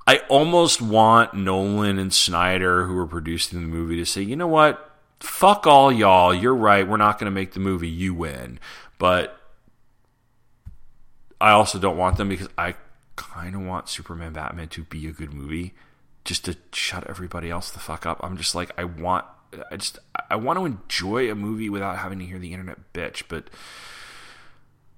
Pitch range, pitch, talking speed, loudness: 85-110 Hz, 95 Hz, 185 wpm, -21 LUFS